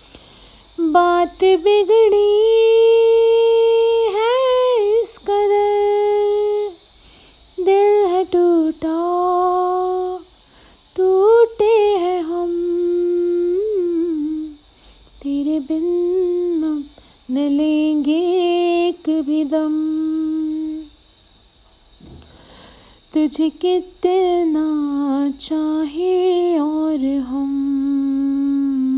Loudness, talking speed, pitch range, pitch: -17 LUFS, 50 wpm, 310-405 Hz, 350 Hz